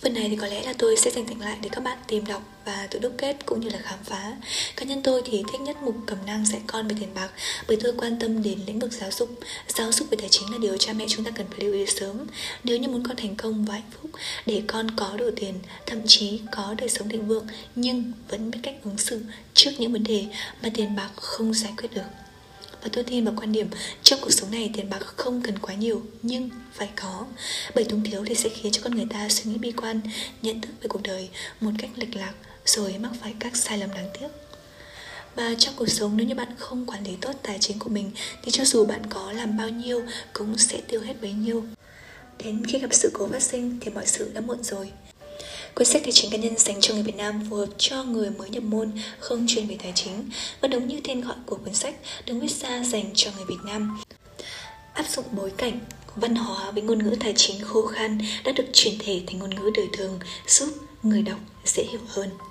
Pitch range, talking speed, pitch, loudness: 205-240 Hz, 250 wpm, 220 Hz, -25 LUFS